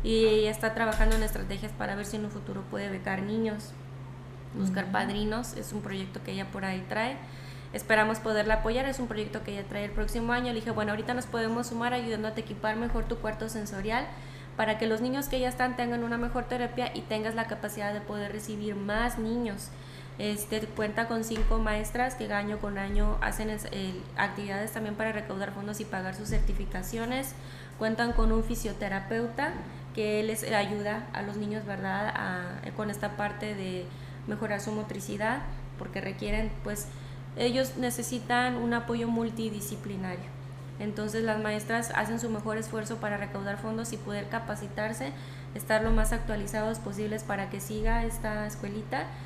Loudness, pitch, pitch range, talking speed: -32 LUFS, 210 Hz, 135-225 Hz, 170 wpm